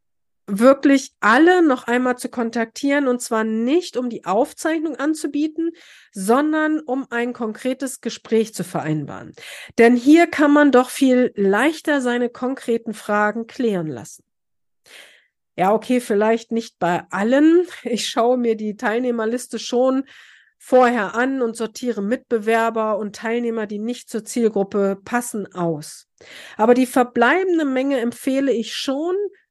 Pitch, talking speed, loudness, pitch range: 240 Hz, 130 wpm, -19 LUFS, 220-270 Hz